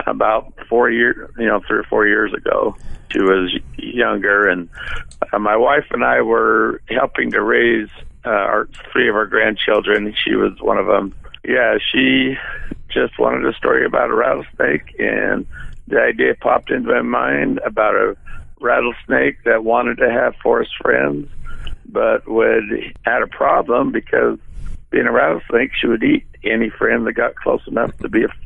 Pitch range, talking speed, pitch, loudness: 70-115 Hz, 165 wpm, 100 Hz, -16 LUFS